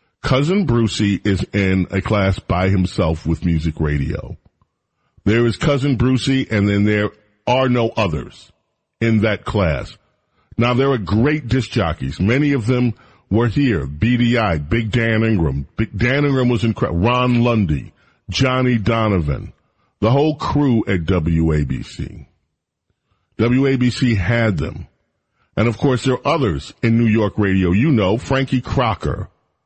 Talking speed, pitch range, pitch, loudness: 140 wpm, 95-125 Hz, 110 Hz, -18 LUFS